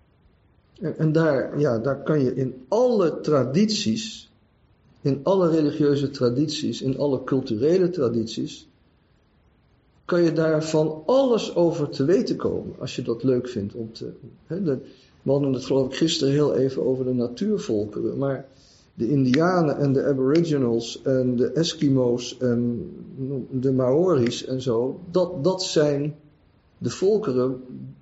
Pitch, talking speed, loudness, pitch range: 135 Hz, 140 wpm, -23 LUFS, 125-160 Hz